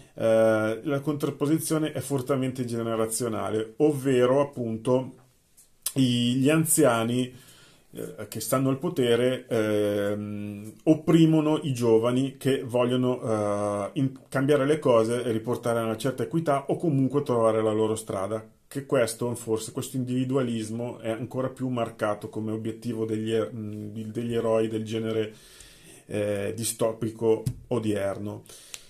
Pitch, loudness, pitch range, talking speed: 120 Hz, -26 LUFS, 110-135 Hz, 105 wpm